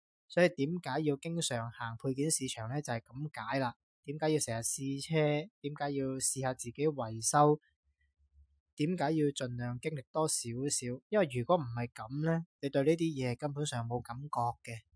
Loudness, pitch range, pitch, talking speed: -34 LUFS, 120-150 Hz, 135 Hz, 255 characters per minute